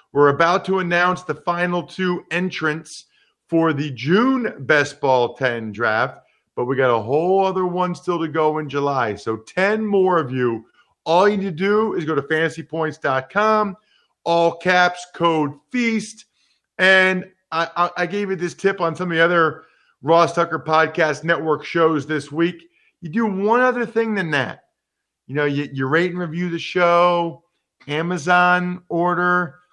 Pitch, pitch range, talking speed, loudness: 170 Hz, 155-185 Hz, 170 wpm, -19 LUFS